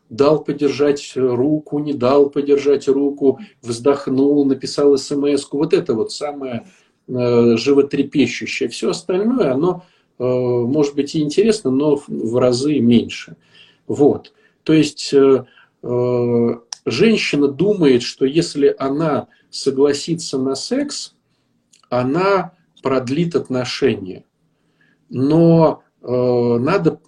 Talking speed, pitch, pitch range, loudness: 95 wpm, 140 Hz, 130-150 Hz, -17 LUFS